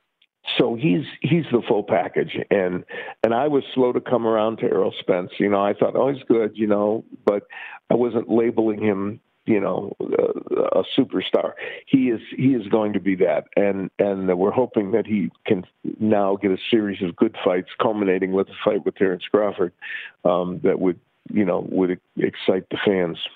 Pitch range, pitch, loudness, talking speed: 100-125 Hz, 110 Hz, -22 LUFS, 190 wpm